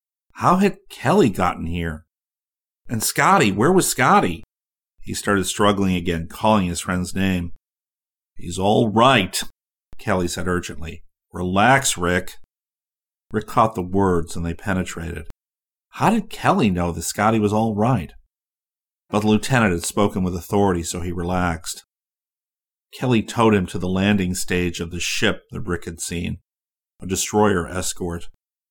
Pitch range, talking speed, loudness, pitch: 85-105 Hz, 145 wpm, -20 LUFS, 90 Hz